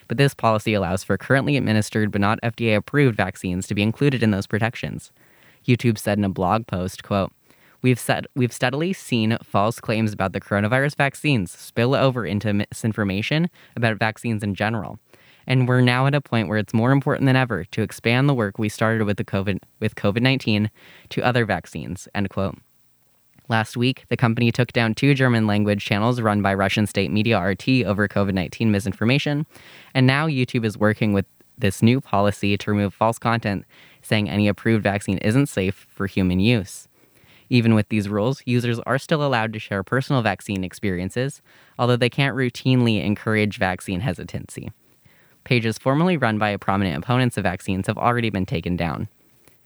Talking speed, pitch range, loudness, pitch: 175 wpm, 100-125 Hz, -21 LUFS, 110 Hz